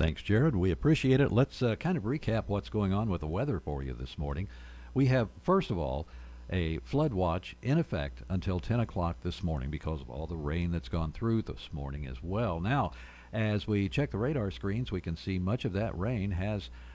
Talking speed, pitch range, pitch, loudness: 220 wpm, 80-115 Hz, 95 Hz, -32 LUFS